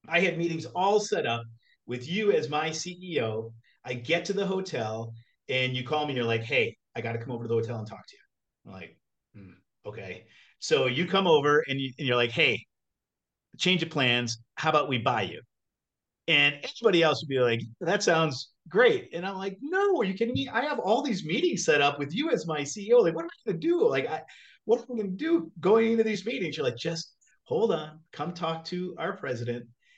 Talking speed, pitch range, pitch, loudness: 230 wpm, 125-195 Hz, 160 Hz, -27 LUFS